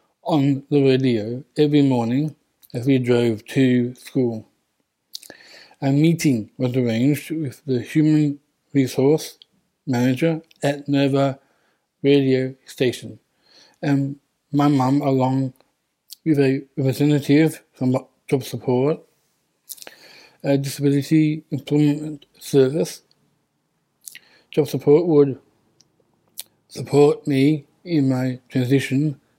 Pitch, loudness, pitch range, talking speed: 140 Hz, -20 LUFS, 130-150 Hz, 90 wpm